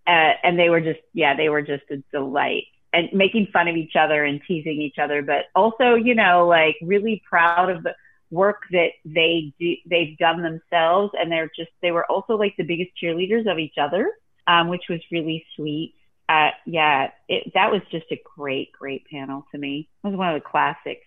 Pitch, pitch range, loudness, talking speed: 170 Hz, 155-180 Hz, -21 LUFS, 210 wpm